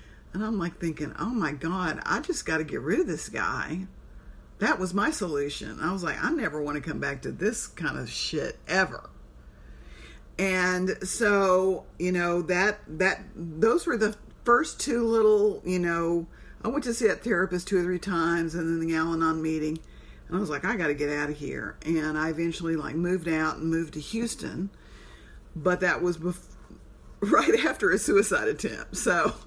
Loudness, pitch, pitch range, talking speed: -27 LUFS, 170 Hz, 155-195 Hz, 200 wpm